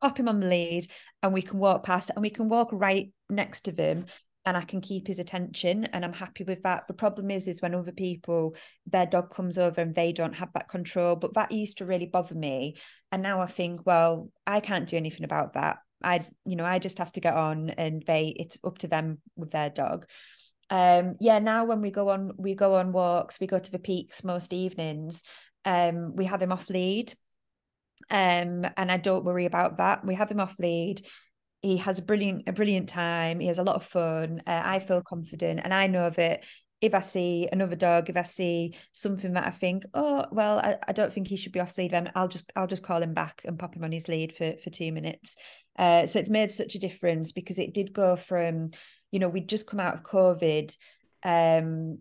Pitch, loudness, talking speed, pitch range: 180 Hz, -28 LUFS, 235 wpm, 170-195 Hz